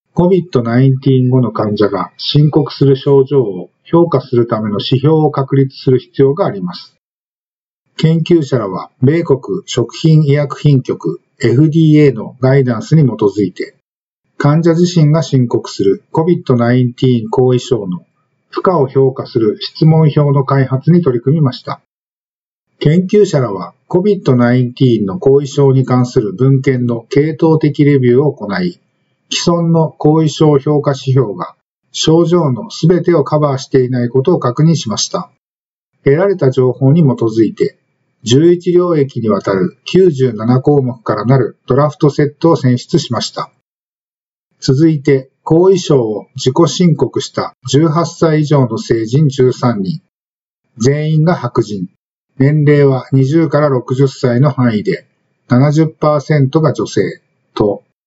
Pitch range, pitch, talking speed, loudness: 130-160 Hz, 140 Hz, 255 characters per minute, -12 LUFS